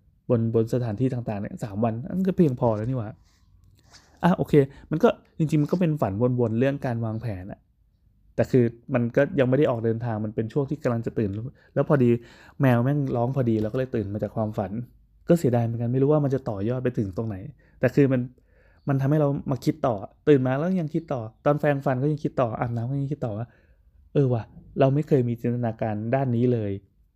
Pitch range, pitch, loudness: 110-140 Hz, 125 Hz, -25 LUFS